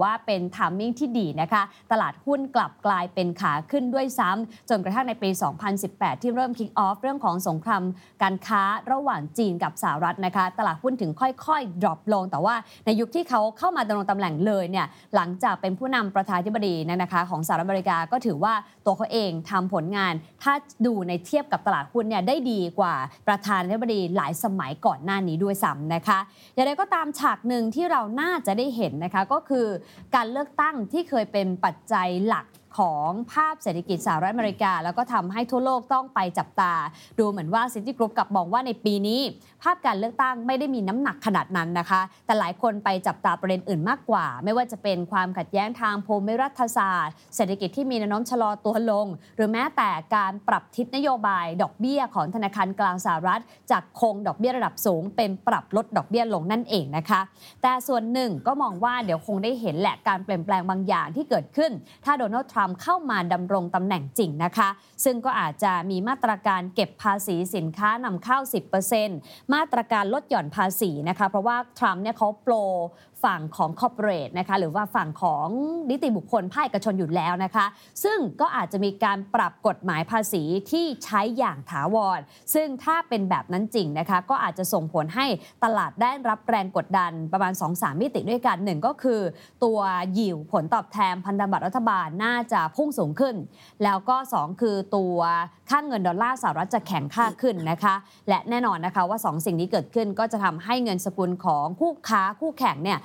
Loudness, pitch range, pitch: -25 LUFS, 185-240 Hz, 210 Hz